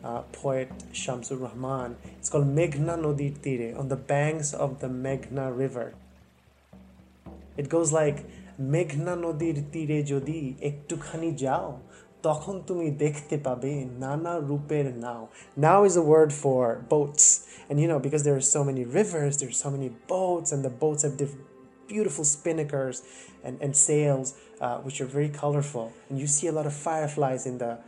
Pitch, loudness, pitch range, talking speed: 145 Hz, -27 LUFS, 130-155 Hz, 160 wpm